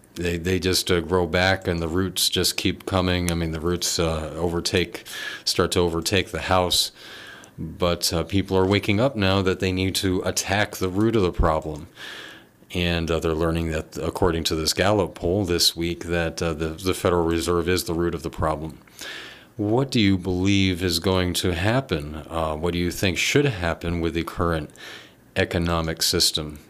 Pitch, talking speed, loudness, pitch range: 85 Hz, 185 wpm, -23 LUFS, 85-95 Hz